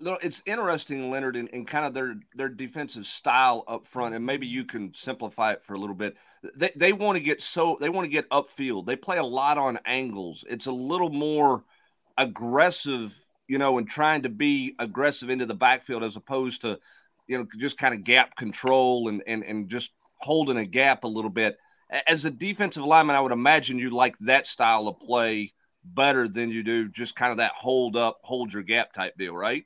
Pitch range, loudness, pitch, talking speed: 120-145 Hz, -25 LUFS, 130 Hz, 210 wpm